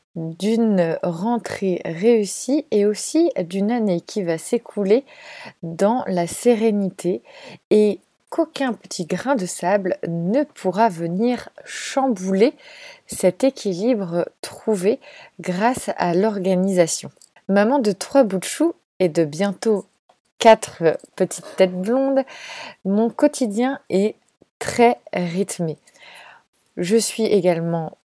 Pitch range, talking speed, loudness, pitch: 185-240 Hz, 105 wpm, -20 LUFS, 205 Hz